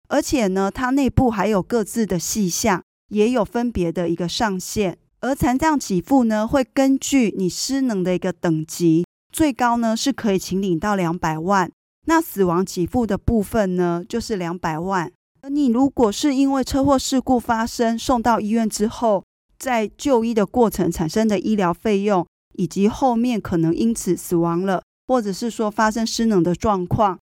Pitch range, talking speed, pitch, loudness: 180-245 Hz, 260 characters per minute, 210 Hz, -20 LUFS